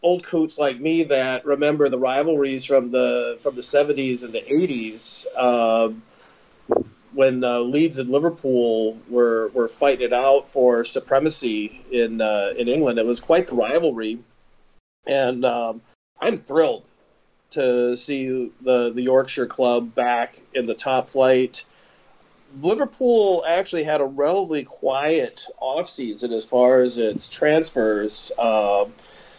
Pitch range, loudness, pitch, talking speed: 120-140 Hz, -21 LUFS, 125 Hz, 135 wpm